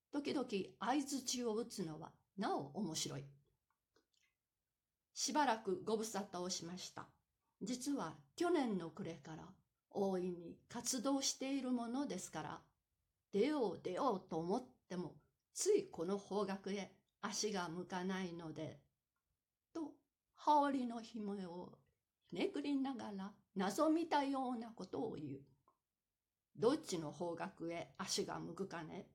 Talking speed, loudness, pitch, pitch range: 235 characters per minute, -42 LUFS, 200 Hz, 175-260 Hz